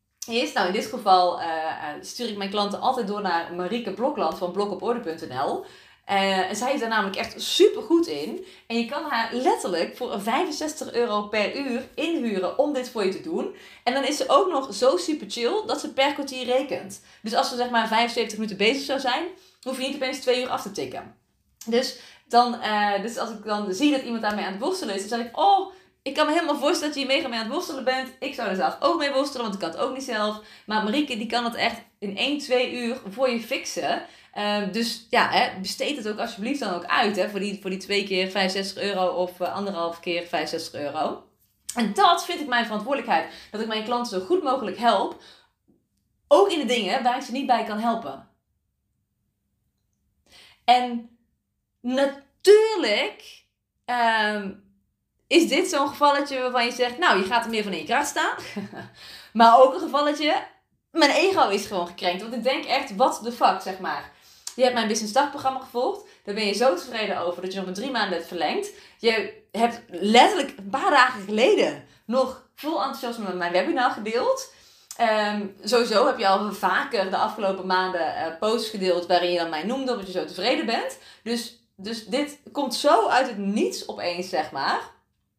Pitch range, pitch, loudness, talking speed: 200-265 Hz, 235 Hz, -24 LUFS, 205 wpm